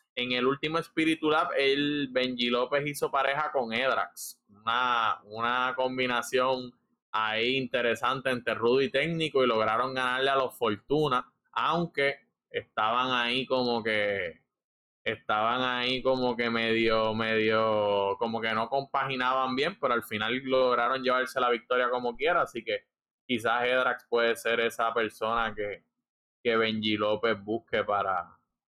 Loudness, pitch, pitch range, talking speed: -28 LUFS, 125 Hz, 115-130 Hz, 140 wpm